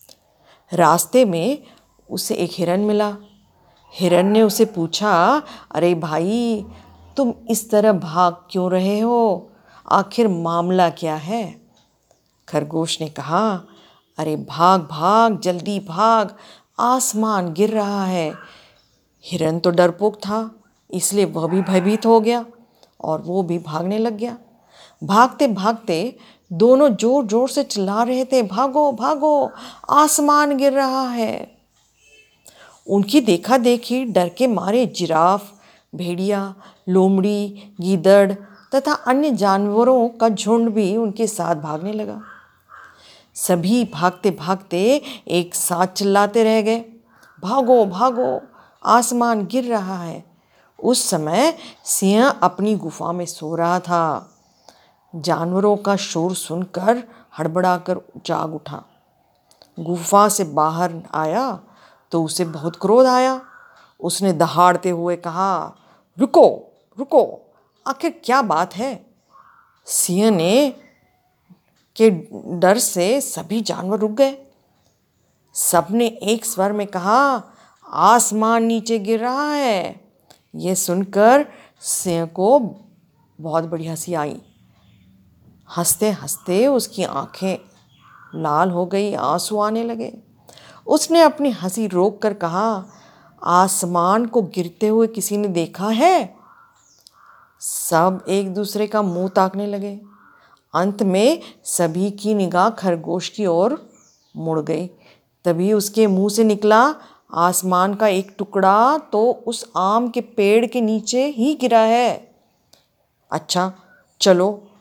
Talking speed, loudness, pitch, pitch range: 115 wpm, -18 LUFS, 205 Hz, 180-230 Hz